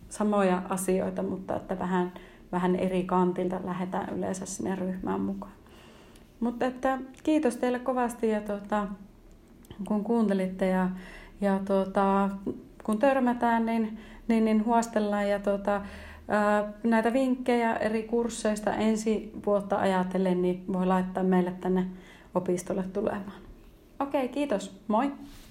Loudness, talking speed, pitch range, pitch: -28 LUFS, 120 wpm, 185-230 Hz, 205 Hz